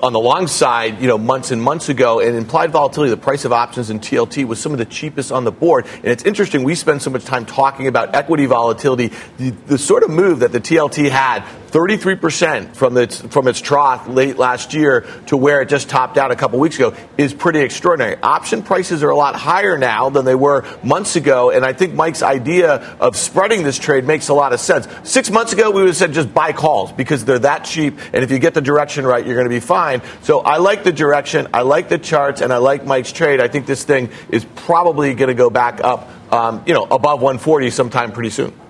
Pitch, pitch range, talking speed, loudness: 140 Hz, 125-160 Hz, 240 wpm, -15 LUFS